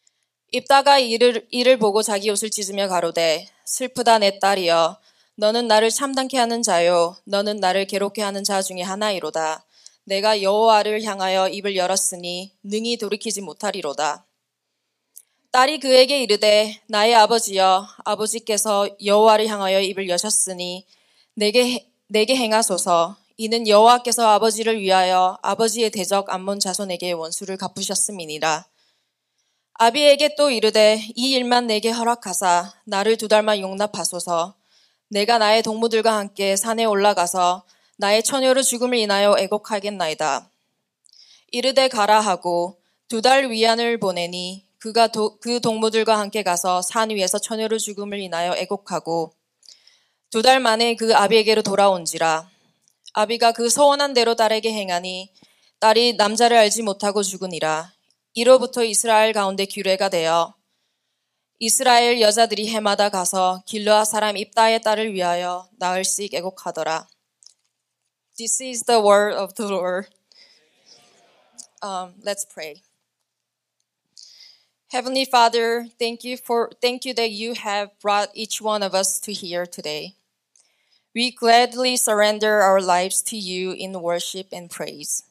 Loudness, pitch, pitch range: -19 LUFS, 210 Hz, 190-230 Hz